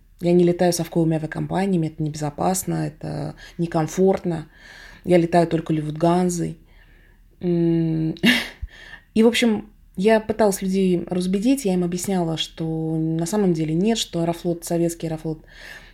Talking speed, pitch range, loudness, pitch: 120 wpm, 160-185 Hz, -21 LUFS, 170 Hz